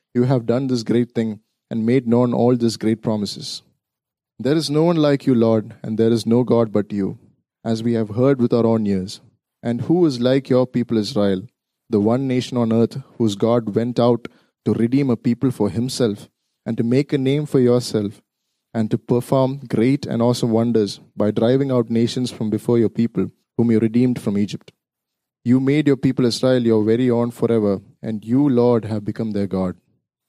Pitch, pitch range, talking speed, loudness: 120 Hz, 110-125 Hz, 200 wpm, -19 LUFS